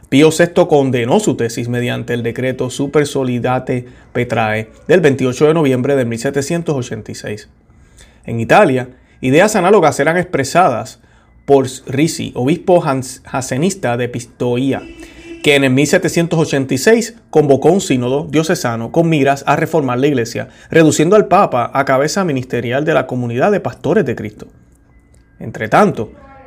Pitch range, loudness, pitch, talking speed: 125-155 Hz, -14 LUFS, 135 Hz, 130 wpm